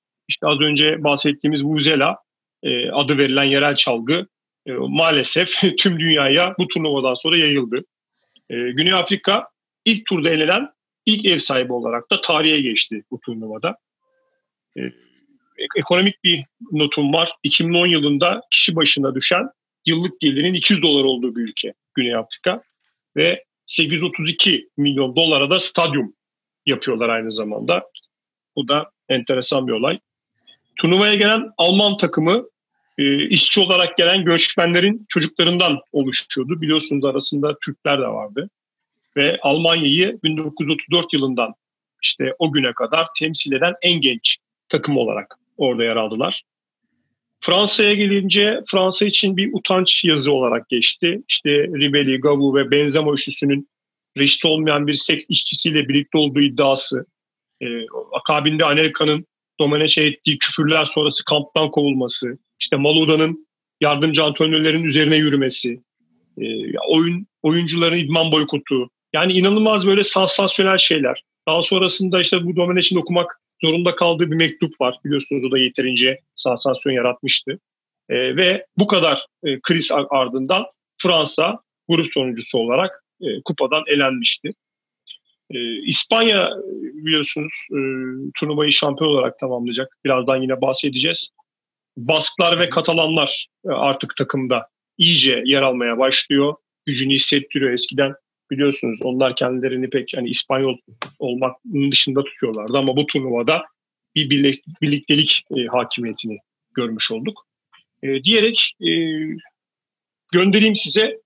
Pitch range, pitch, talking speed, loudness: 140-175 Hz, 155 Hz, 115 wpm, -17 LUFS